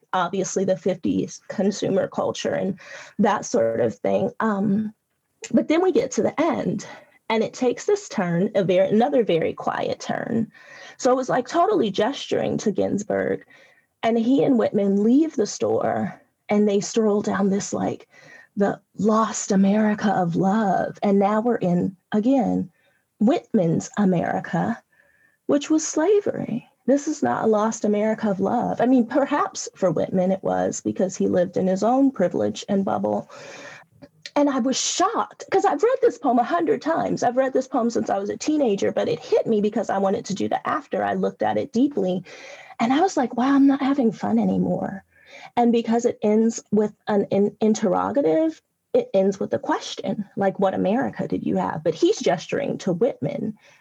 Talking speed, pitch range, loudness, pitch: 175 wpm, 195-270 Hz, -22 LUFS, 220 Hz